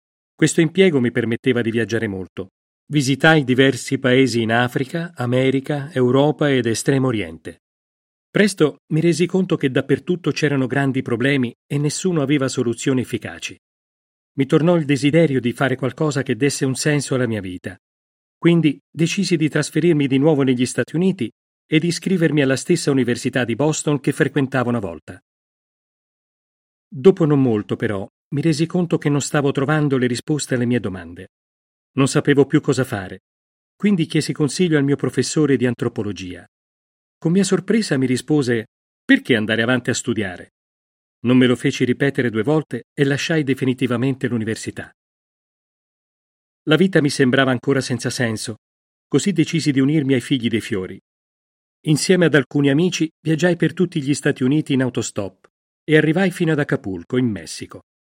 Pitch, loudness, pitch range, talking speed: 135 Hz, -19 LUFS, 120-155 Hz, 155 wpm